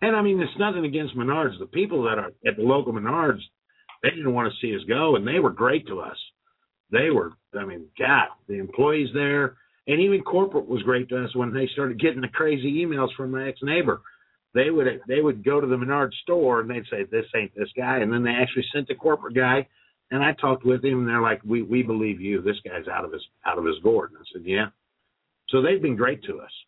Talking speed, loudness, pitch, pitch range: 245 wpm, -24 LUFS, 135 Hz, 125-160 Hz